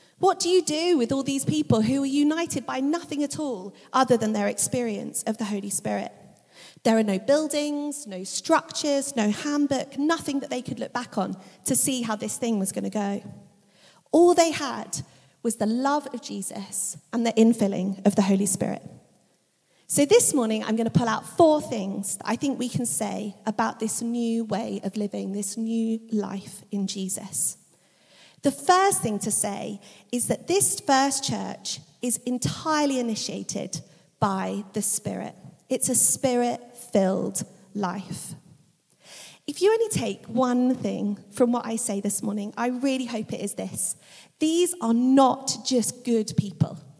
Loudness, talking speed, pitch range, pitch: -25 LUFS, 170 wpm, 200-270 Hz, 225 Hz